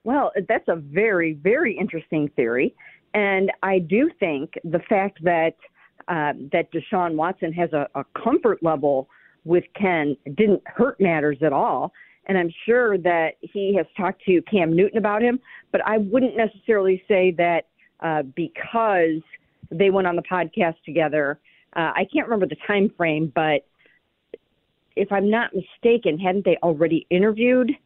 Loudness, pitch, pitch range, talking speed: -22 LUFS, 185 Hz, 165-215 Hz, 155 wpm